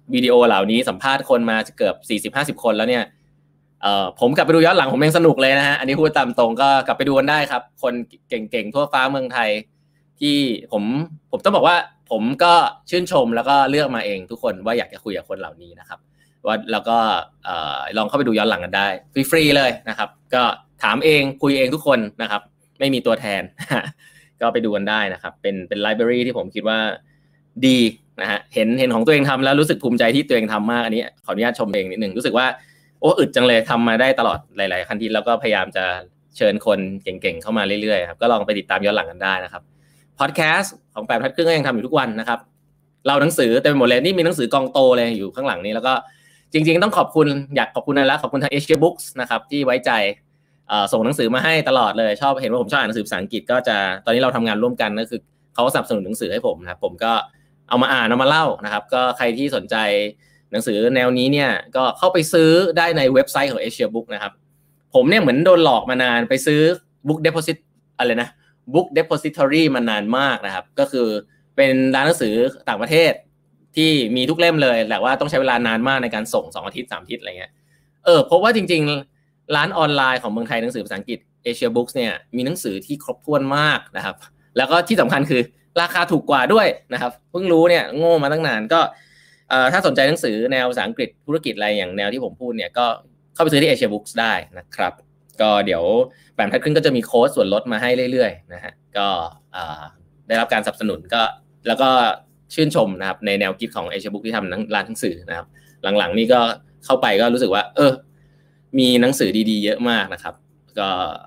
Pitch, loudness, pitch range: 135 Hz, -18 LUFS, 115-150 Hz